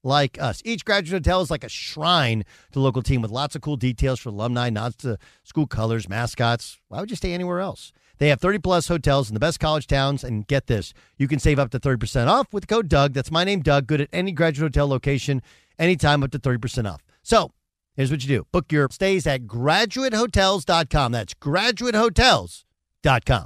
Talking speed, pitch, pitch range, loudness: 205 wpm, 140 Hz, 125-170 Hz, -22 LUFS